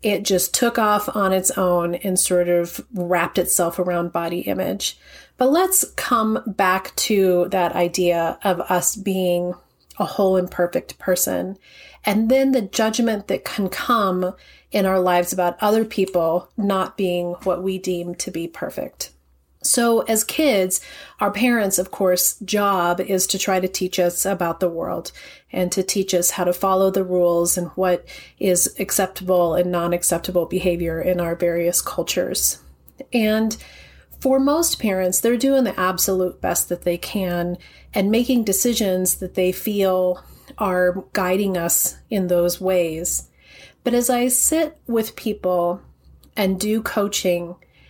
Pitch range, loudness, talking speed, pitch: 175-205 Hz, -20 LUFS, 150 wpm, 185 Hz